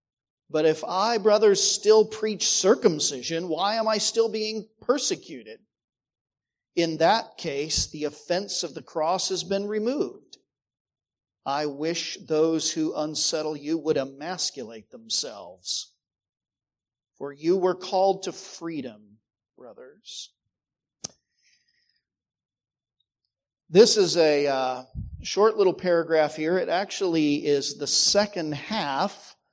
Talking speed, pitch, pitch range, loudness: 110 wpm, 165 Hz, 150-215 Hz, -24 LUFS